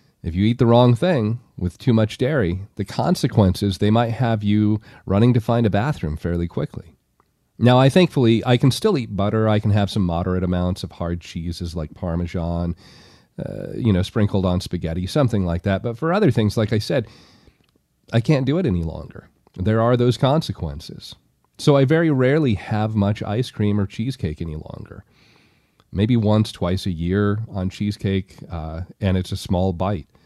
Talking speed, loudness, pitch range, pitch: 185 wpm, -20 LUFS, 90-120 Hz, 105 Hz